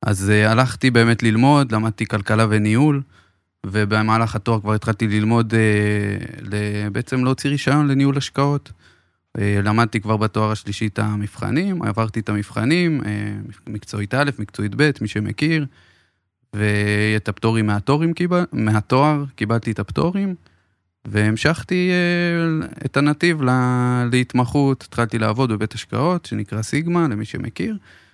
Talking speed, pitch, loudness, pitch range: 125 wpm, 115 Hz, -19 LUFS, 105-140 Hz